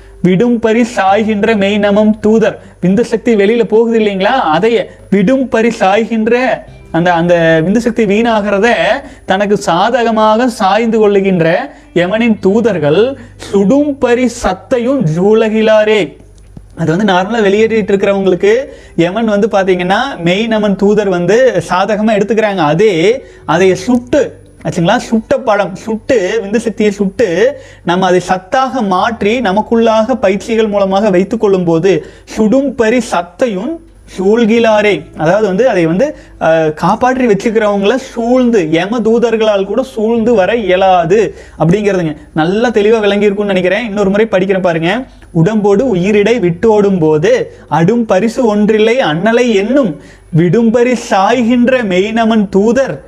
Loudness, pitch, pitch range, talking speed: -11 LUFS, 215 Hz, 190-235 Hz, 115 wpm